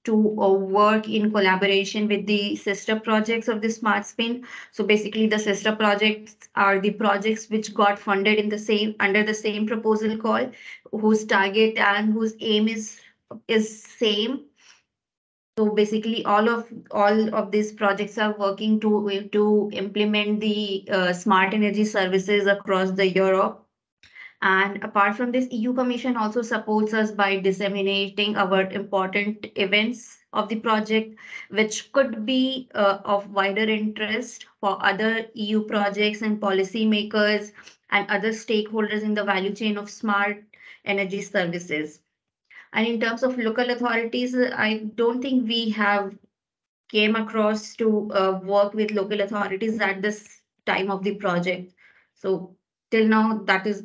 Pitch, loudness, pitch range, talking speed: 210 Hz, -23 LUFS, 200-220 Hz, 145 wpm